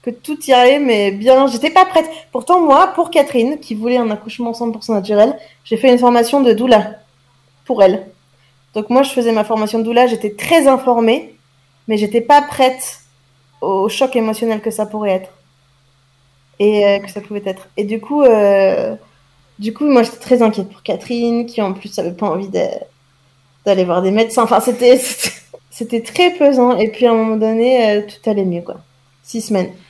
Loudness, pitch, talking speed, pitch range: -14 LUFS, 225 Hz, 190 wpm, 195-250 Hz